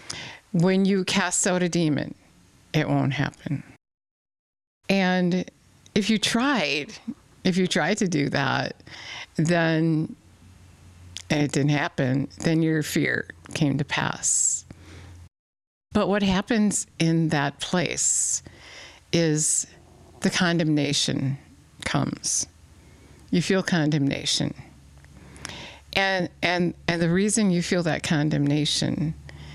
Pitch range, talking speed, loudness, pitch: 130-180 Hz, 105 wpm, -24 LUFS, 155 Hz